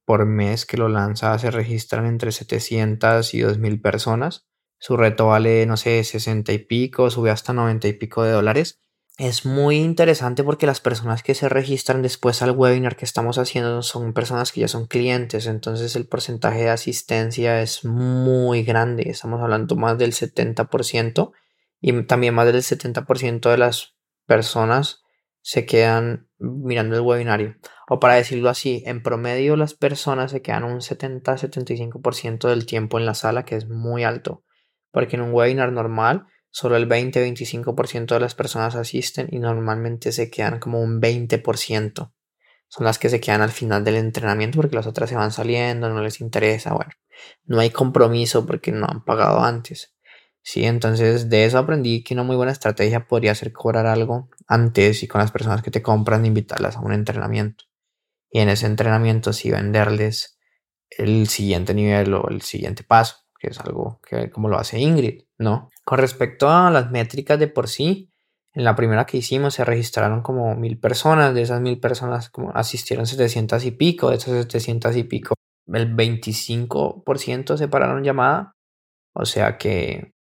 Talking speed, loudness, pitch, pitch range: 175 wpm, -20 LUFS, 115 Hz, 110-125 Hz